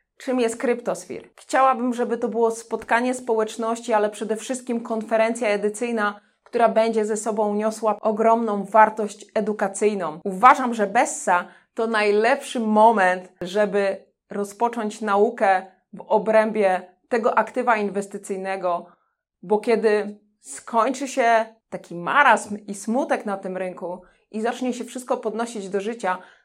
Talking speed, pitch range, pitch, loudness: 125 wpm, 200-230 Hz, 220 Hz, -22 LUFS